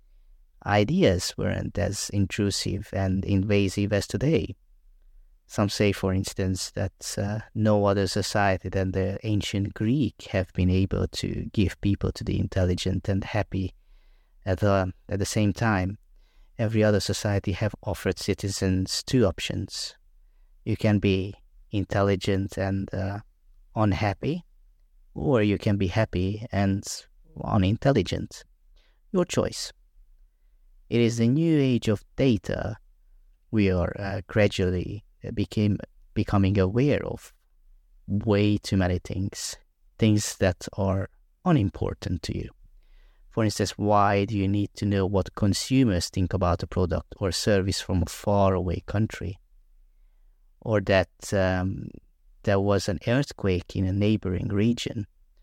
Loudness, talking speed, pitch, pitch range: -26 LUFS, 130 wpm, 100 Hz, 95-105 Hz